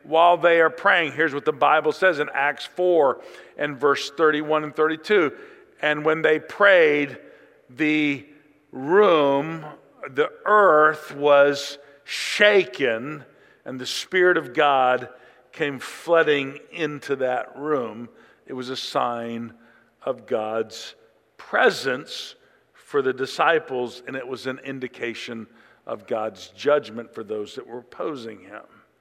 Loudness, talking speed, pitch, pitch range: -21 LUFS, 125 wpm, 145 Hz, 130-160 Hz